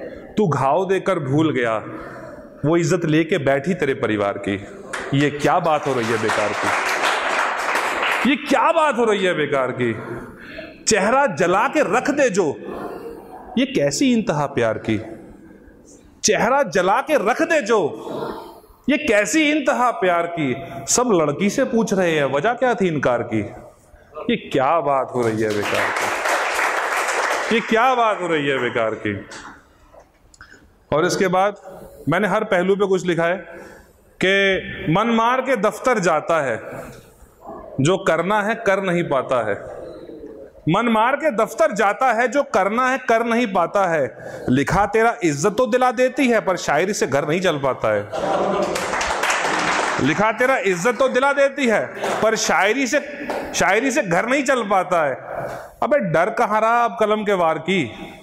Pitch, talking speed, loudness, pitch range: 195 Hz, 160 wpm, -19 LUFS, 155-245 Hz